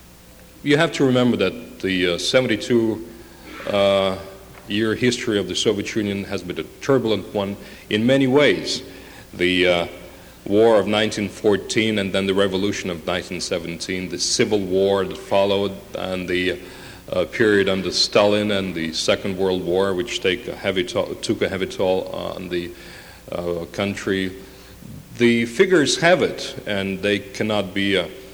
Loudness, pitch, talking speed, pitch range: -20 LUFS, 100 Hz, 150 wpm, 95-110 Hz